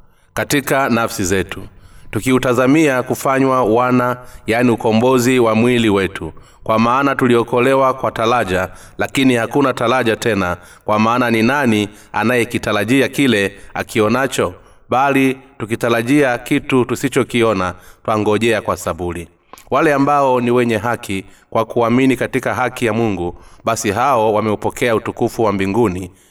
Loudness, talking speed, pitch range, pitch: -16 LUFS, 115 wpm, 105-125 Hz, 115 Hz